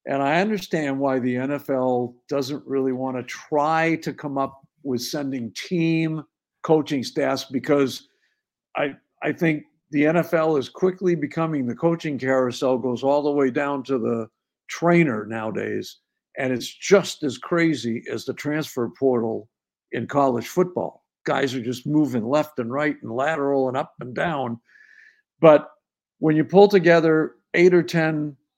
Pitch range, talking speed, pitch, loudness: 130-160 Hz, 155 wpm, 145 Hz, -22 LUFS